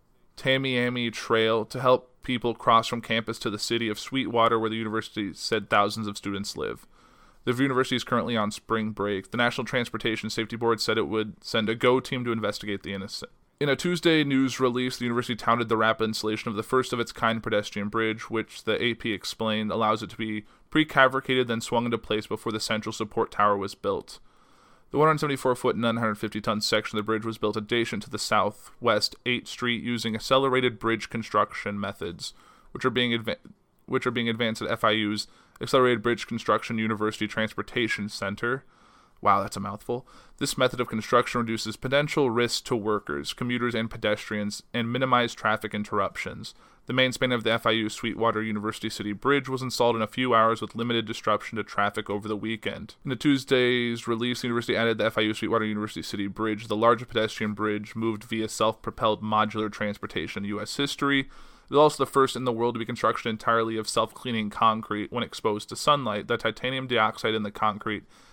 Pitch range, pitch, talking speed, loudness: 110-125 Hz, 115 Hz, 185 wpm, -26 LUFS